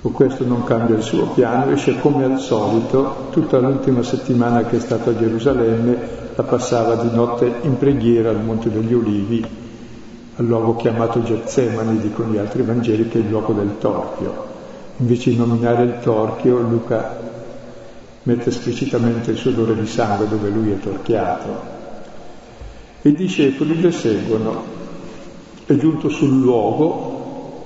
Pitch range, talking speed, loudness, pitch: 115-130 Hz, 150 wpm, -18 LUFS, 120 Hz